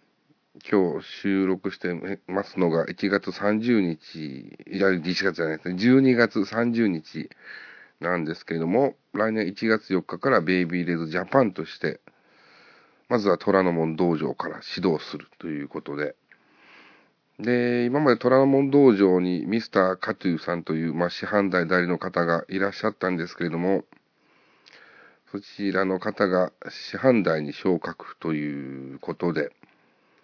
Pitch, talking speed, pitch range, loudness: 95 Hz, 265 characters per minute, 85-105 Hz, -24 LUFS